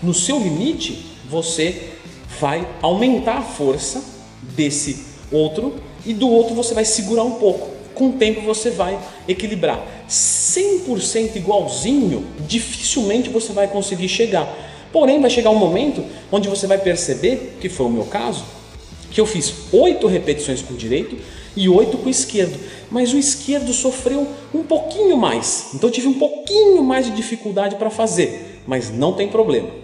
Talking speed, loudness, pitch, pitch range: 160 wpm, -18 LUFS, 215 Hz, 175-245 Hz